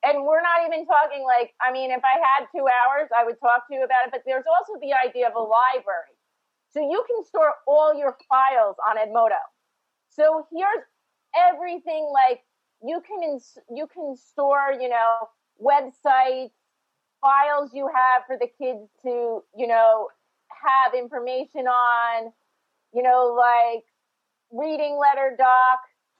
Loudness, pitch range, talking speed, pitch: -21 LUFS, 245-300 Hz, 155 wpm, 260 Hz